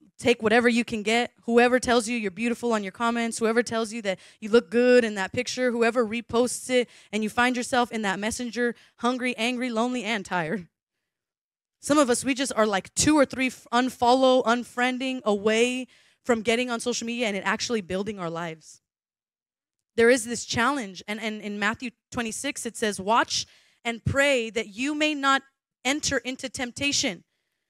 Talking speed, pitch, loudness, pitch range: 180 wpm, 235 Hz, -25 LUFS, 220-250 Hz